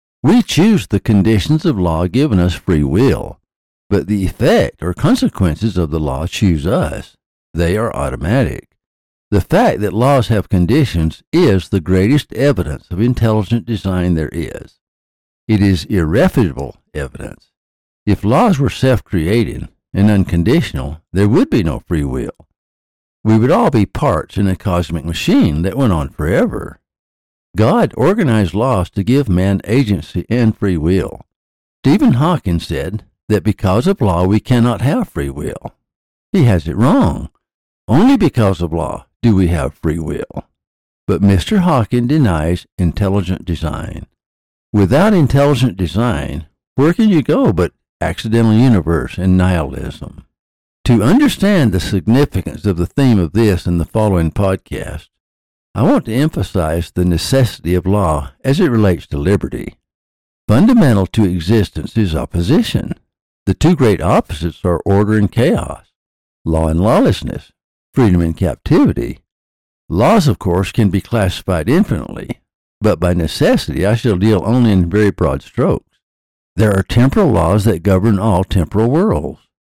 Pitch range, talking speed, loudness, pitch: 85-115 Hz, 145 wpm, -14 LUFS, 95 Hz